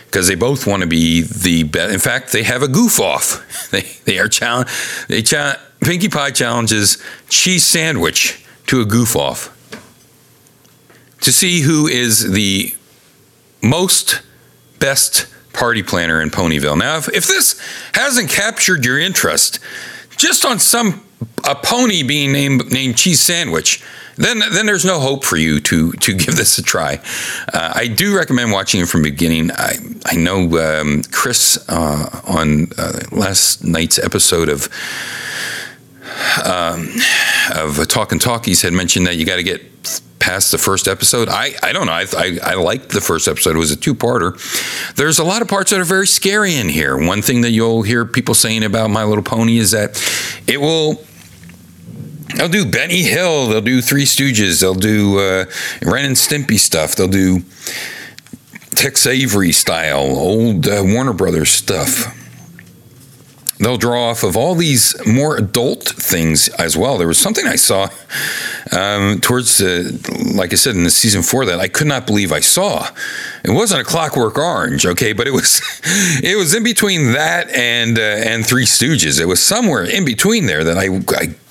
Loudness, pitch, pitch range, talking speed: -13 LUFS, 115 Hz, 90-140 Hz, 175 wpm